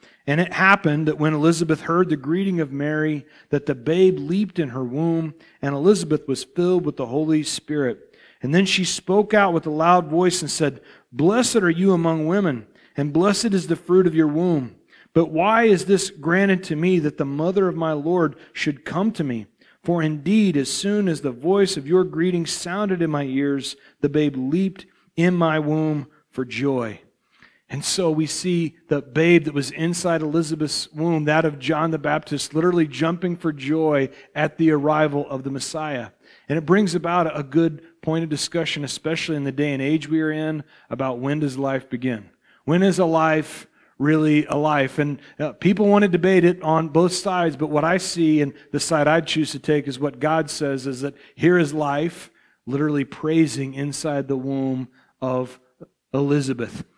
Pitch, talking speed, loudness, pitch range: 155 Hz, 190 wpm, -21 LUFS, 145-175 Hz